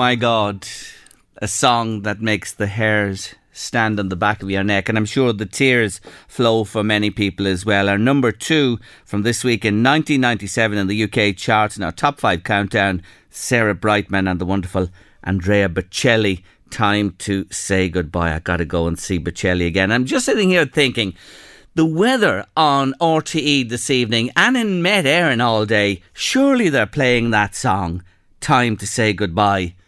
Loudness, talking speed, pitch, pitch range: -17 LUFS, 175 wpm, 105 Hz, 95-125 Hz